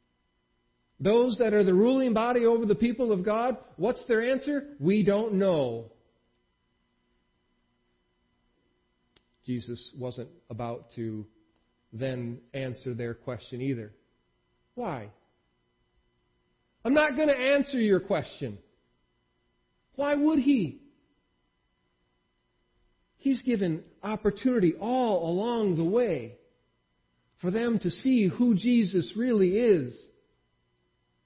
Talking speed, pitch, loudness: 100 wpm, 145 Hz, -27 LUFS